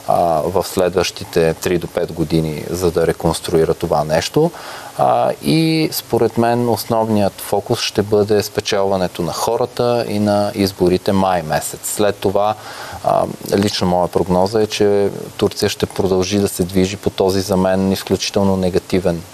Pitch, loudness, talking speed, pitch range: 100 Hz, -17 LUFS, 140 wpm, 95-105 Hz